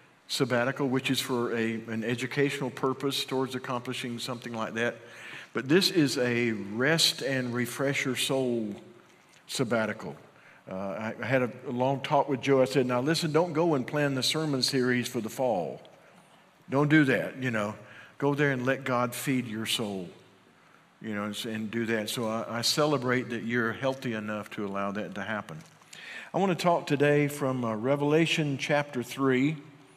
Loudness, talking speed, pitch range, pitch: -28 LUFS, 175 wpm, 115-140 Hz, 130 Hz